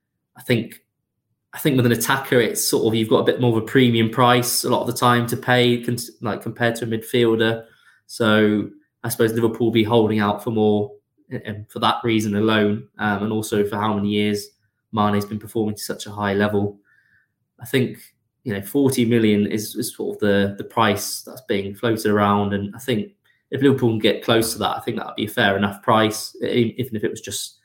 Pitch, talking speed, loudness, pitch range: 110 Hz, 225 wpm, -20 LUFS, 105-120 Hz